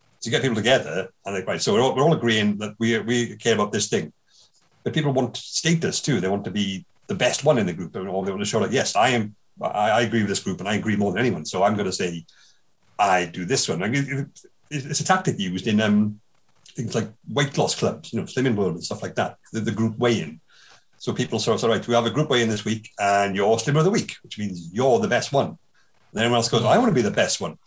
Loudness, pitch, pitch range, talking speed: -23 LUFS, 115 Hz, 105-140 Hz, 280 wpm